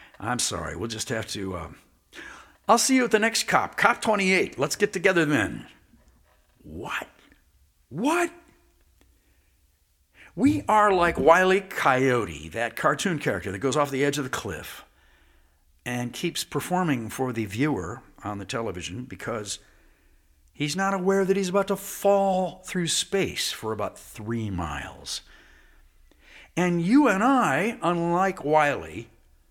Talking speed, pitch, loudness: 140 wpm, 135 Hz, -25 LUFS